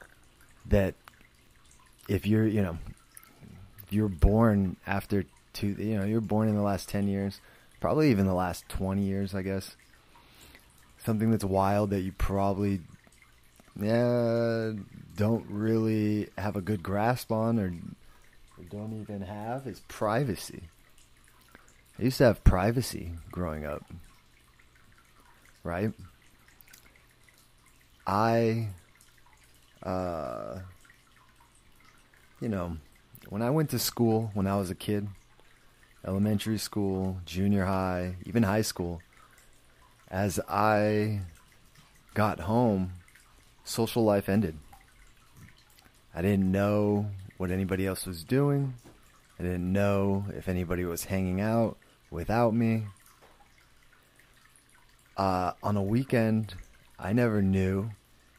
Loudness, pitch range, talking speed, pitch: -29 LUFS, 95-110 Hz, 110 wpm, 100 Hz